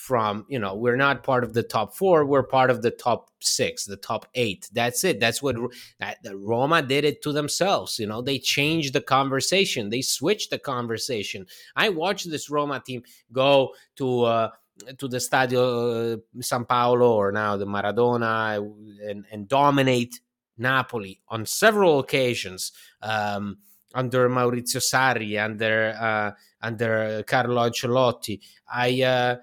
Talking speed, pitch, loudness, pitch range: 155 wpm, 120 Hz, -23 LUFS, 110-130 Hz